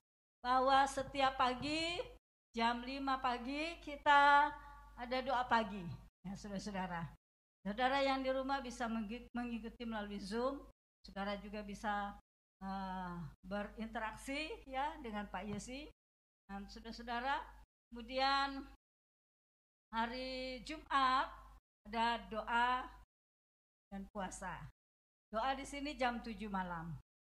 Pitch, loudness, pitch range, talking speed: 235 Hz, -39 LUFS, 205-270 Hz, 95 wpm